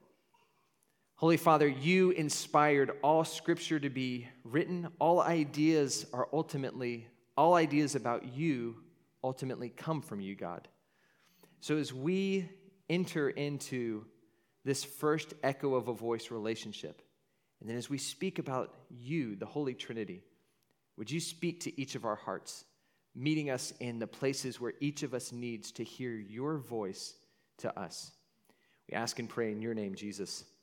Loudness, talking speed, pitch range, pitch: -34 LUFS, 150 wpm, 120-160 Hz, 140 Hz